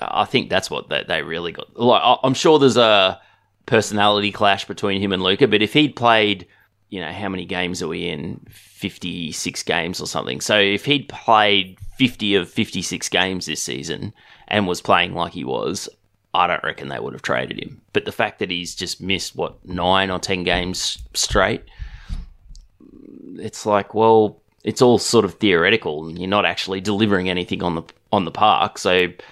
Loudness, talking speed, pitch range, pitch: -19 LUFS, 185 wpm, 90-105 Hz, 100 Hz